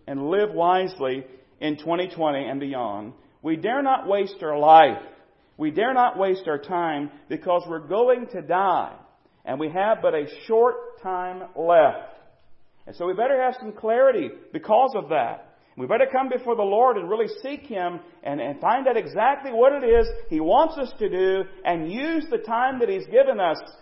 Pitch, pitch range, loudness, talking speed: 220 Hz, 175-280 Hz, -22 LUFS, 185 wpm